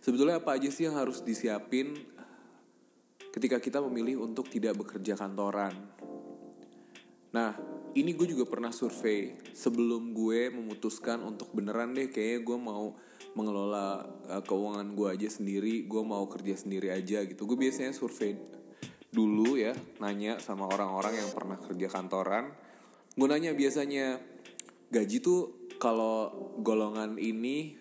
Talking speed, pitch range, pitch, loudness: 130 wpm, 100-130 Hz, 110 Hz, -33 LUFS